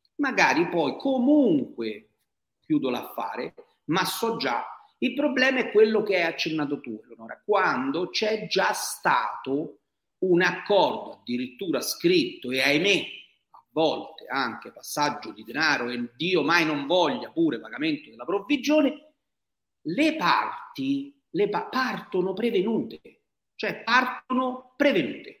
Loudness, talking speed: -25 LUFS, 120 wpm